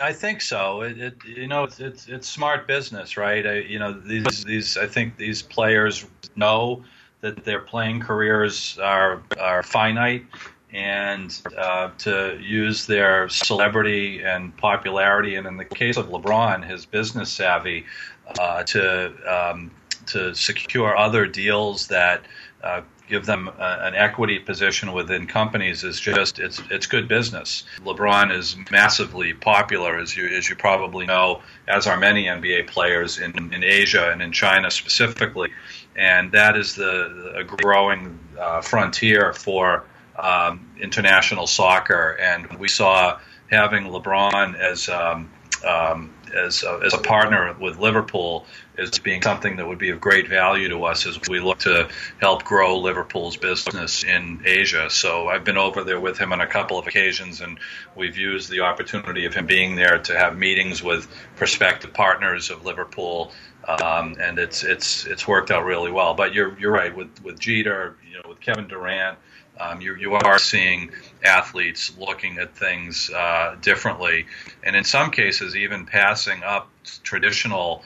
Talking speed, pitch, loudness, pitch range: 160 wpm, 100 Hz, -20 LUFS, 90-110 Hz